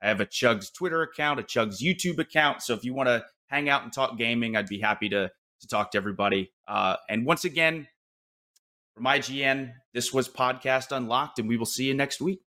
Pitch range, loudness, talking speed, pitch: 115-145 Hz, -27 LUFS, 215 wpm, 130 Hz